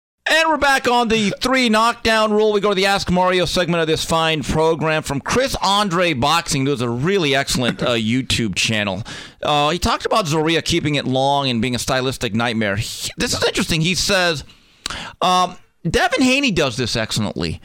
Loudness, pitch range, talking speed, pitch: -17 LUFS, 130-200 Hz, 185 wpm, 160 Hz